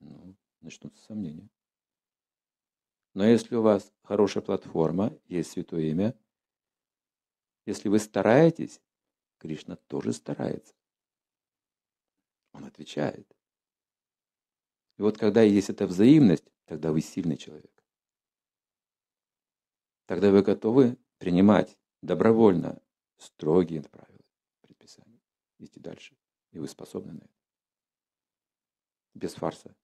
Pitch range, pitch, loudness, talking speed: 90-110 Hz, 100 Hz, -25 LUFS, 95 wpm